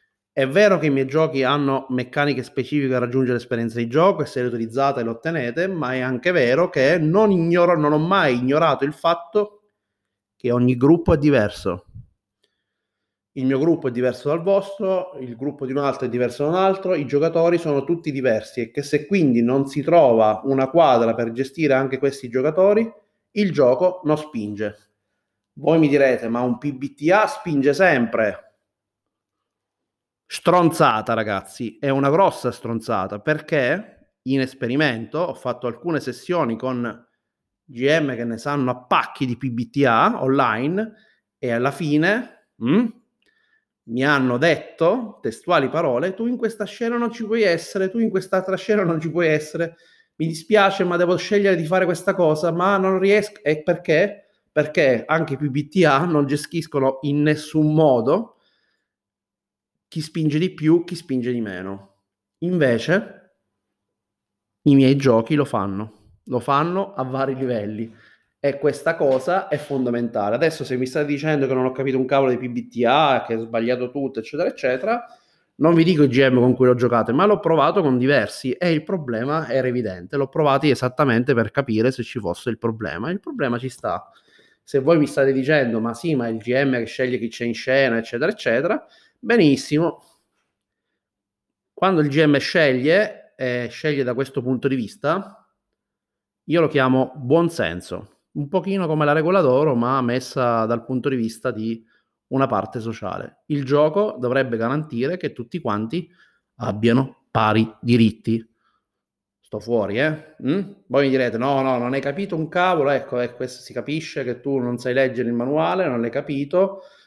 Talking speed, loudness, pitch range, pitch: 165 wpm, -20 LUFS, 125-165 Hz, 140 Hz